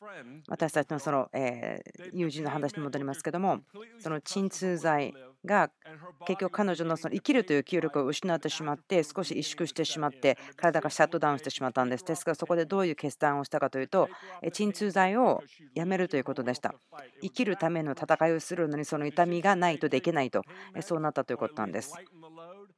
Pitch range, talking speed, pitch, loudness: 145-180 Hz, 390 characters per minute, 160 Hz, -30 LUFS